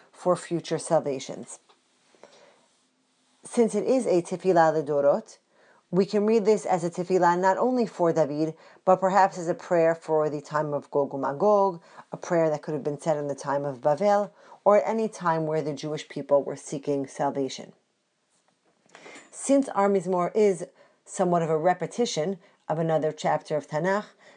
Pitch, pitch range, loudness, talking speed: 170 Hz, 150-195 Hz, -25 LUFS, 165 wpm